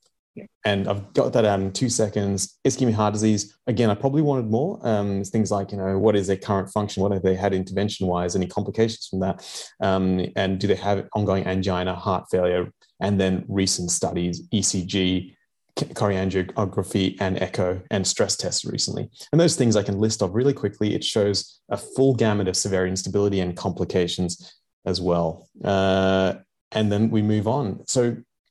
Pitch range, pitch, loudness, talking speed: 95-105 Hz, 100 Hz, -23 LUFS, 180 wpm